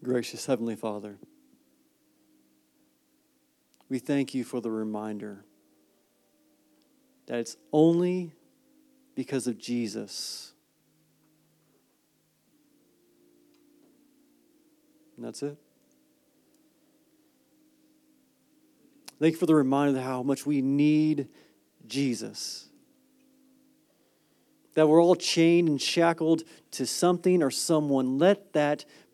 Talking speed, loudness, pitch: 85 wpm, -27 LUFS, 180 Hz